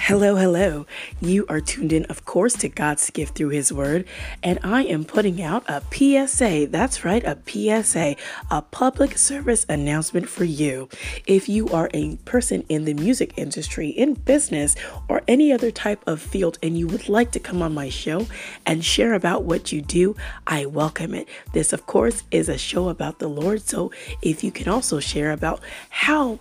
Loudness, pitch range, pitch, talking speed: -21 LUFS, 155-230 Hz, 180 Hz, 190 wpm